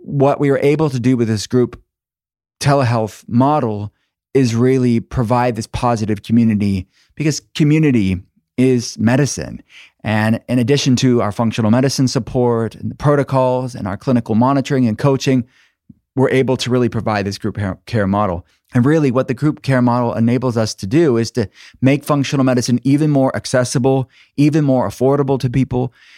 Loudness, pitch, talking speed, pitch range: -16 LUFS, 125 Hz, 165 wpm, 110-135 Hz